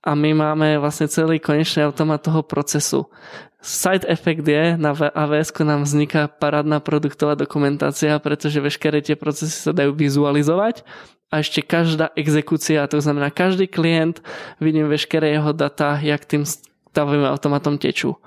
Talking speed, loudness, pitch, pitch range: 145 wpm, -19 LUFS, 150 Hz, 150-160 Hz